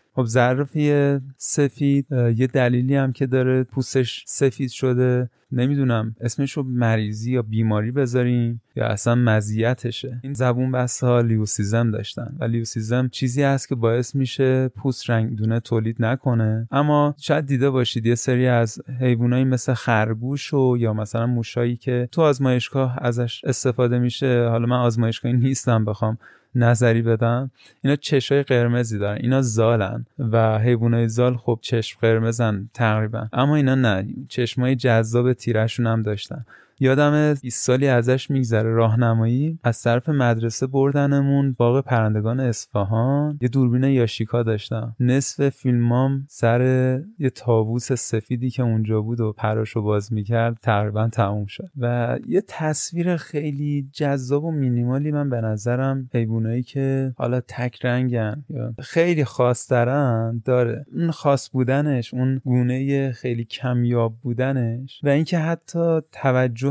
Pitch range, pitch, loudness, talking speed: 115-135 Hz, 125 Hz, -21 LUFS, 135 wpm